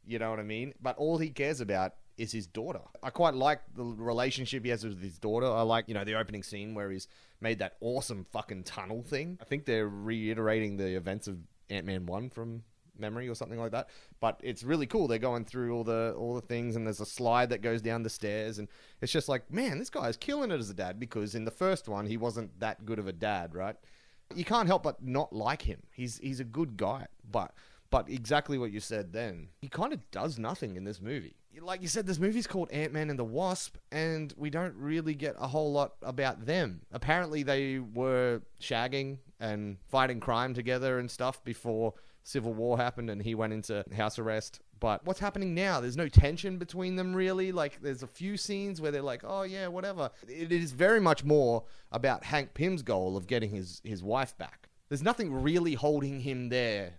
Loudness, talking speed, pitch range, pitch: -33 LUFS, 220 wpm, 110-150 Hz, 120 Hz